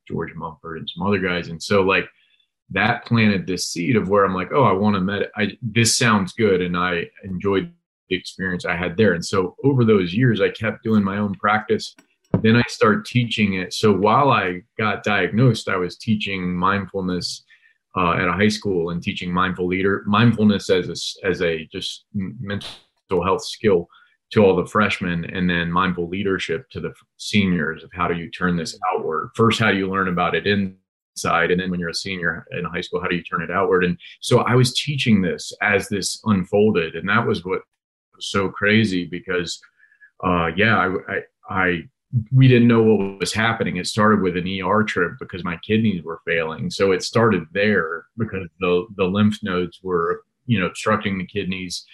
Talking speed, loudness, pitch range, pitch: 200 wpm, -20 LUFS, 90-110 Hz, 100 Hz